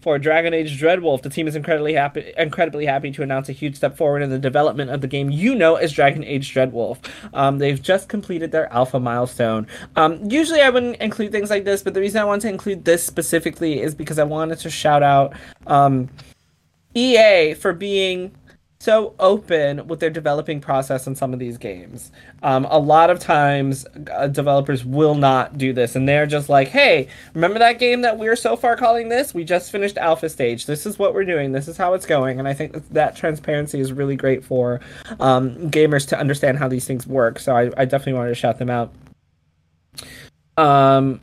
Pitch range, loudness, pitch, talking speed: 135-175 Hz, -18 LUFS, 150 Hz, 205 wpm